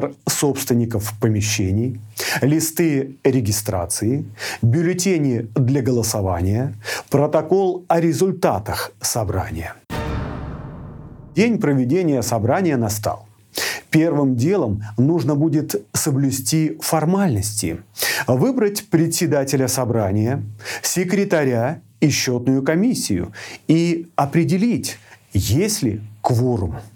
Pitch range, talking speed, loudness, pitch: 110-160 Hz, 75 wpm, -19 LUFS, 135 Hz